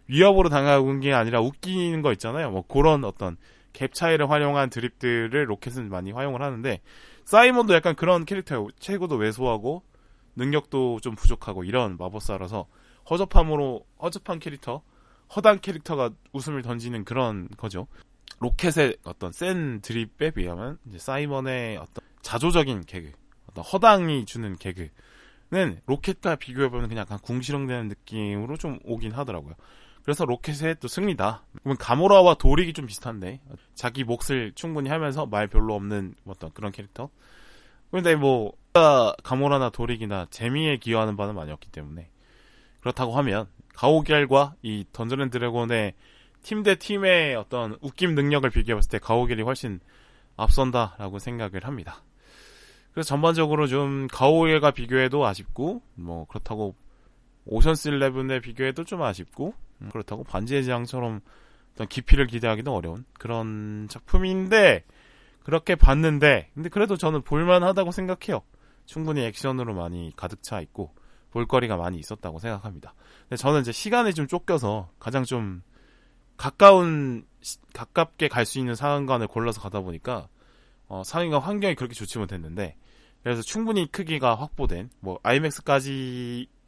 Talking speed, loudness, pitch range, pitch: 340 characters per minute, -24 LUFS, 110-150 Hz, 130 Hz